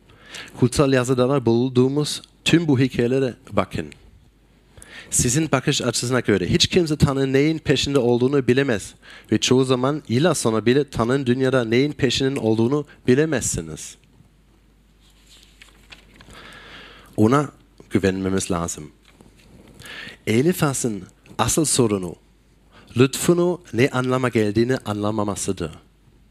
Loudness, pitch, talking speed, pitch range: -20 LUFS, 125 Hz, 95 wpm, 110-140 Hz